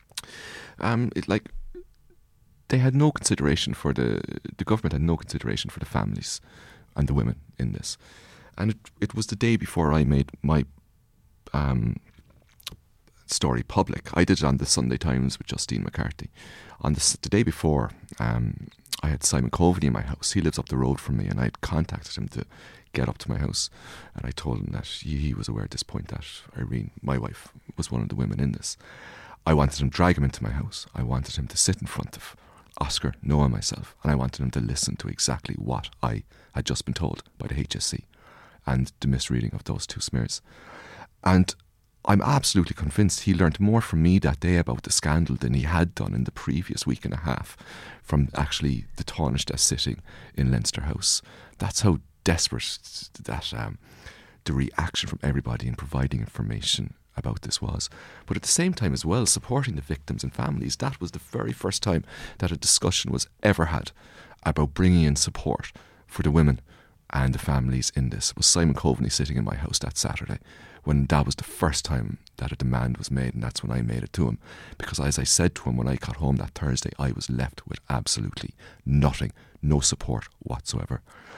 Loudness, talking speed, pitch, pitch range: -26 LUFS, 205 wpm, 75 Hz, 65-95 Hz